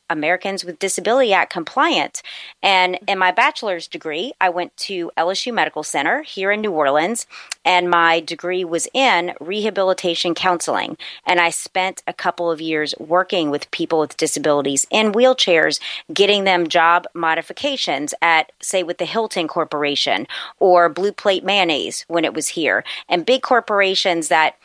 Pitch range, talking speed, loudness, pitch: 165-195 Hz, 155 wpm, -18 LUFS, 180 Hz